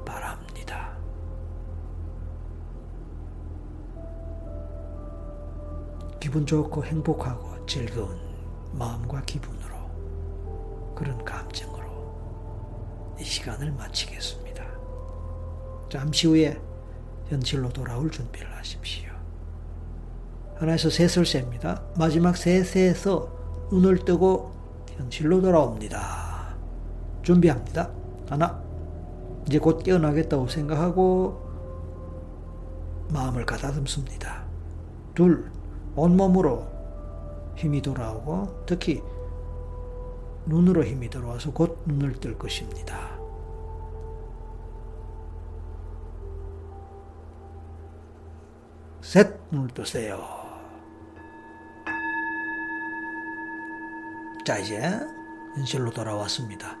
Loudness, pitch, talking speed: -26 LUFS, 90 Hz, 170 characters per minute